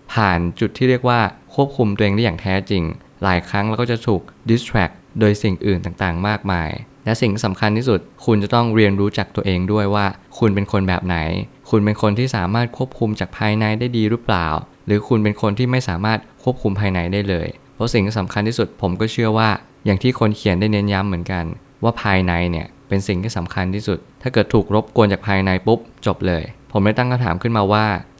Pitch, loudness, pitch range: 105 Hz, -19 LUFS, 95-115 Hz